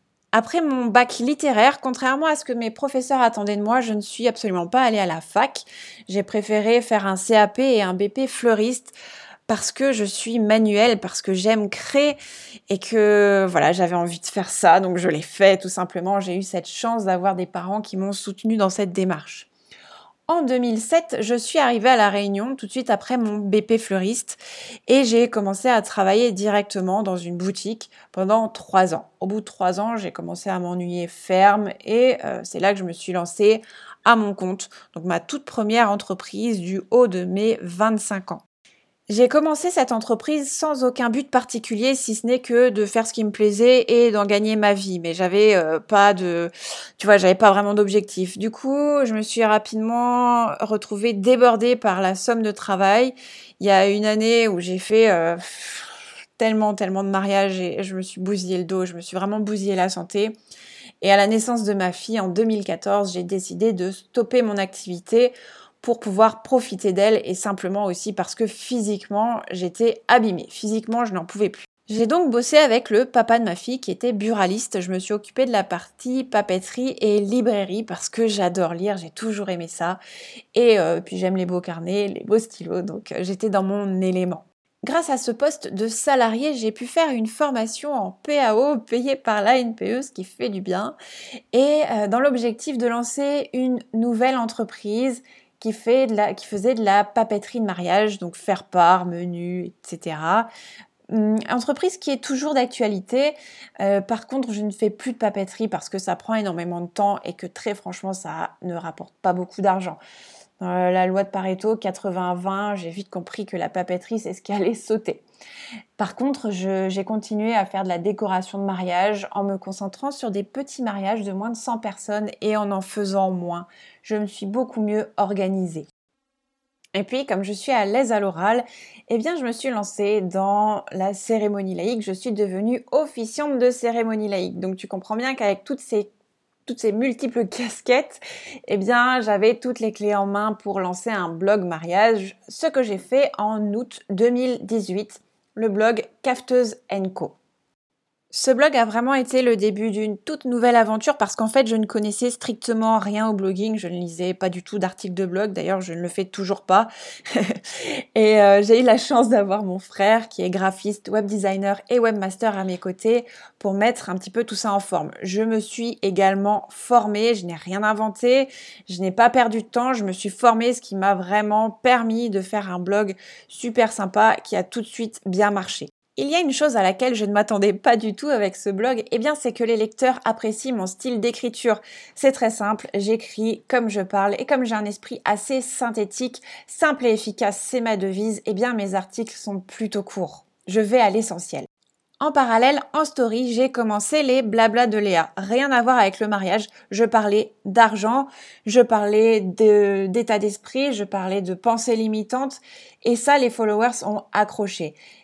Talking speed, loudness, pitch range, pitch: 195 wpm, -21 LUFS, 195-240 Hz, 215 Hz